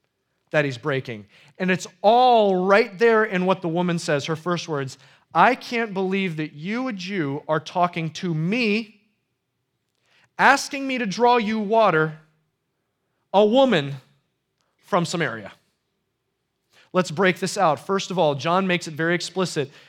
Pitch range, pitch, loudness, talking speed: 155-215 Hz, 185 Hz, -21 LUFS, 150 wpm